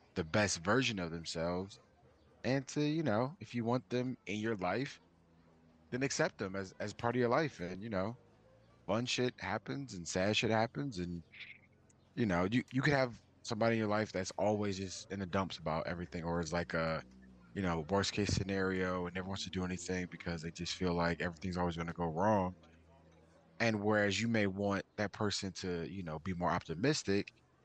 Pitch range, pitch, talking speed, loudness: 85-110 Hz, 95 Hz, 200 wpm, -36 LUFS